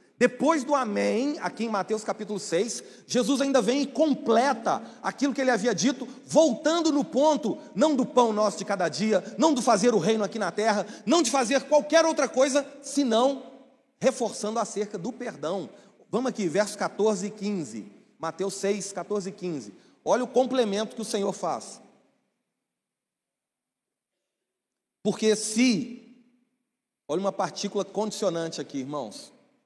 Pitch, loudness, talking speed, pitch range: 230 Hz, -26 LUFS, 150 wpm, 205-265 Hz